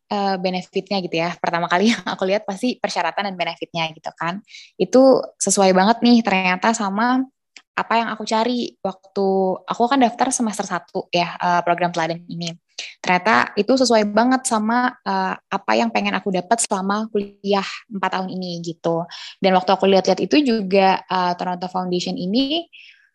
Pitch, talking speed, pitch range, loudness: 195 Hz, 165 wpm, 180-225 Hz, -20 LUFS